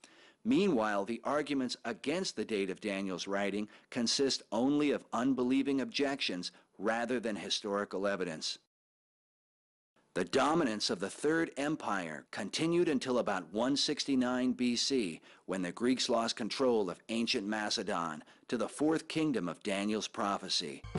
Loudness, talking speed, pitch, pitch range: -33 LUFS, 125 wpm, 120 Hz, 105-140 Hz